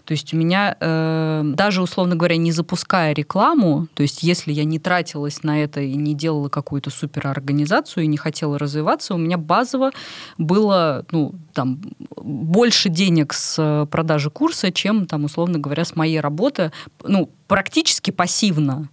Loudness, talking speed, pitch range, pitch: -19 LUFS, 150 wpm, 150-185 Hz, 160 Hz